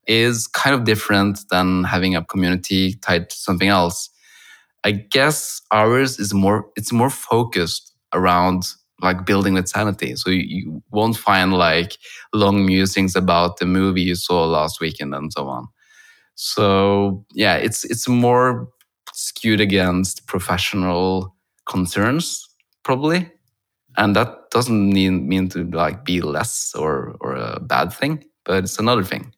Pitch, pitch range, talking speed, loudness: 95 Hz, 90-110 Hz, 145 wpm, -19 LUFS